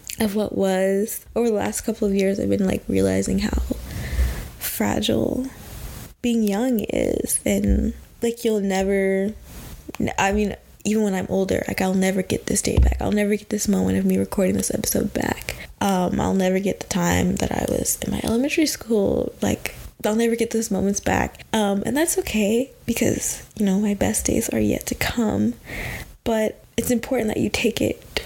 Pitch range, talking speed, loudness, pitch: 190-230 Hz, 185 wpm, -22 LUFS, 210 Hz